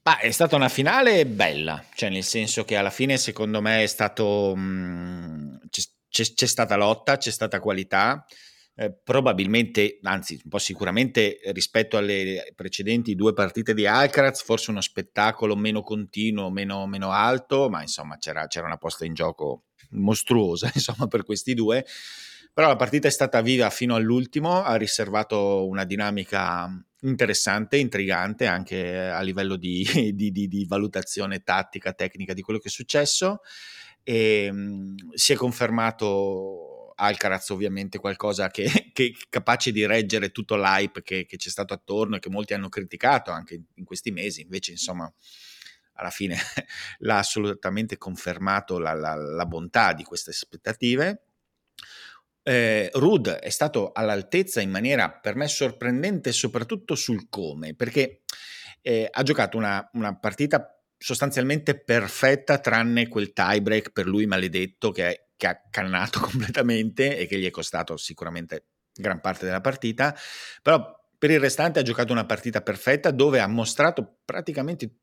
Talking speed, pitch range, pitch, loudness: 150 wpm, 95-125 Hz, 105 Hz, -24 LUFS